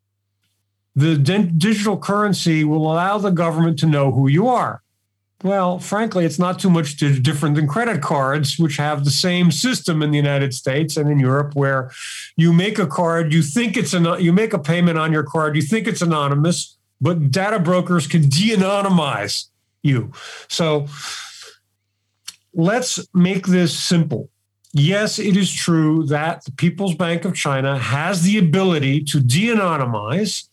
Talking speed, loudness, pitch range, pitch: 160 wpm, -18 LUFS, 140-185 Hz, 165 Hz